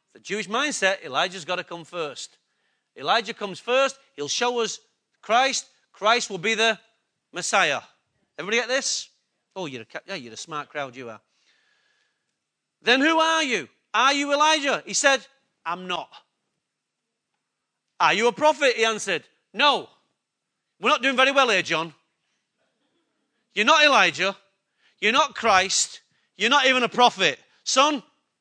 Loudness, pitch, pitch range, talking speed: -22 LUFS, 230 Hz, 190-275 Hz, 150 wpm